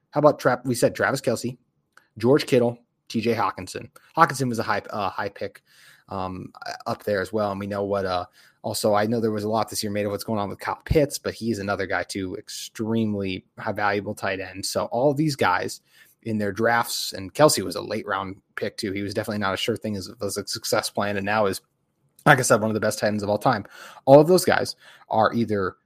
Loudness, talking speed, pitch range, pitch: -24 LUFS, 240 wpm, 100-115 Hz, 105 Hz